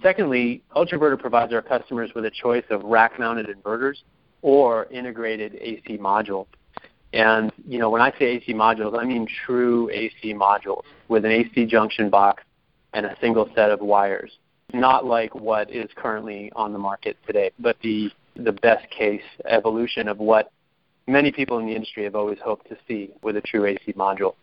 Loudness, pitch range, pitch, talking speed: -22 LUFS, 105-120 Hz, 110 Hz, 185 wpm